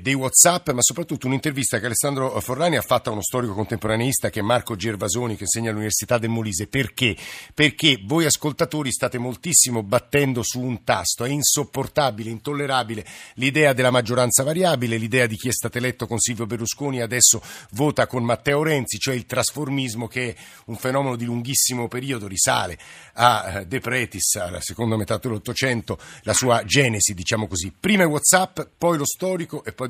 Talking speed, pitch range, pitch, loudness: 170 wpm, 115-135 Hz, 125 Hz, -21 LUFS